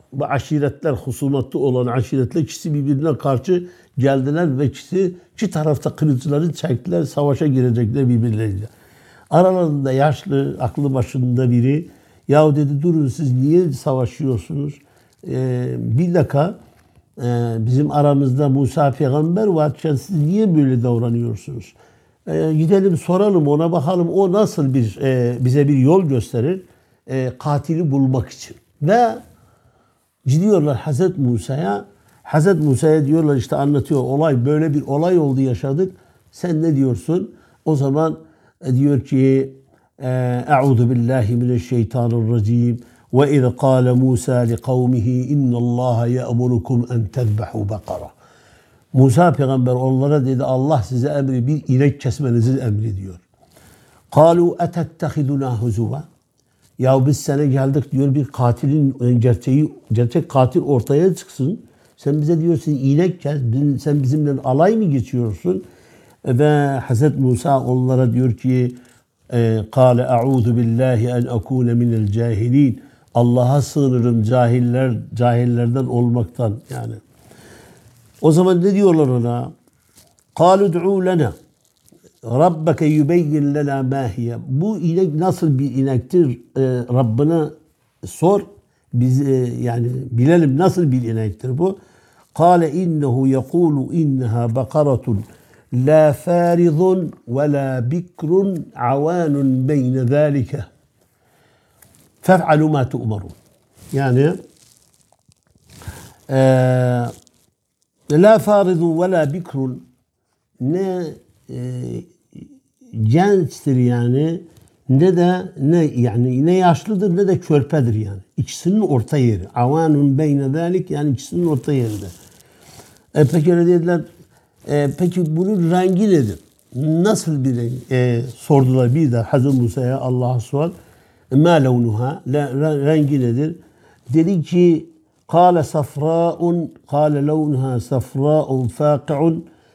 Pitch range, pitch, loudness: 125-160 Hz, 140 Hz, -17 LUFS